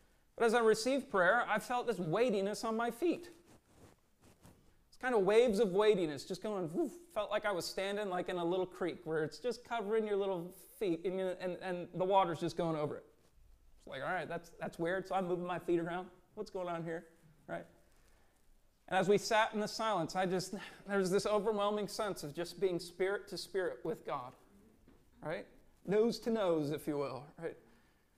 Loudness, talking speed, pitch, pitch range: -36 LUFS, 200 wpm, 190 Hz, 170-215 Hz